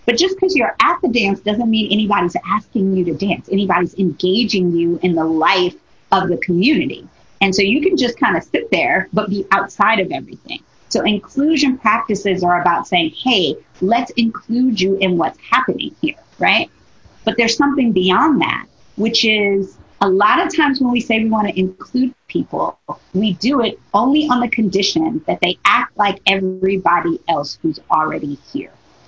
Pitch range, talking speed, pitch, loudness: 185-240 Hz, 180 wpm, 200 Hz, -16 LUFS